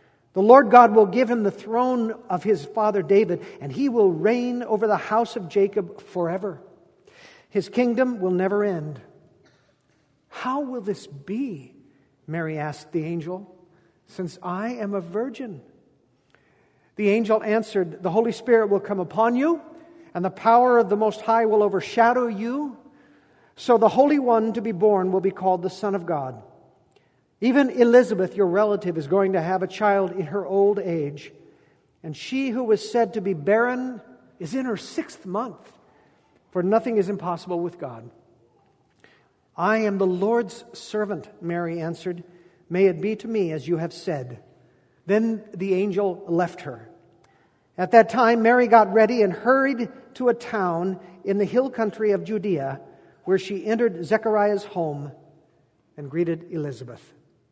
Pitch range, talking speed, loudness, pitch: 180-230 Hz, 160 wpm, -22 LUFS, 205 Hz